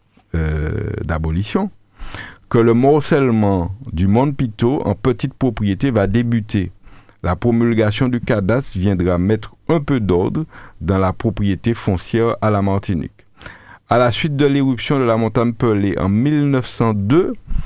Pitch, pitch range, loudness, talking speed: 110 Hz, 100-125 Hz, -17 LUFS, 135 wpm